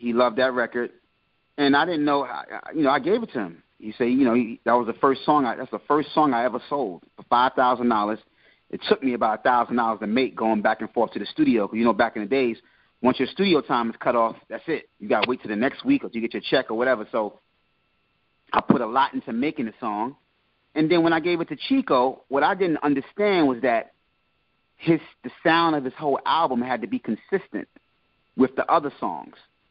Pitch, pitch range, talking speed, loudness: 130 Hz, 120-155 Hz, 240 wpm, -23 LUFS